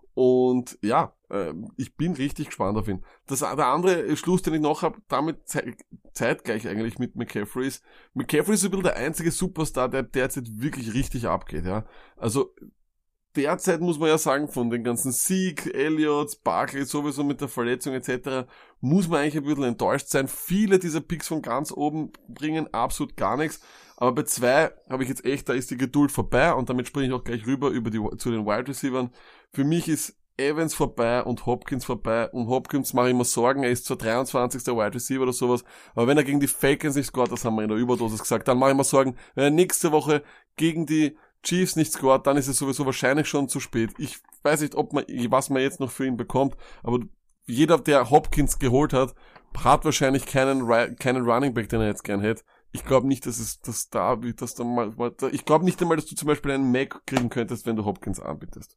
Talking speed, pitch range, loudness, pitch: 215 wpm, 120-150 Hz, -25 LUFS, 135 Hz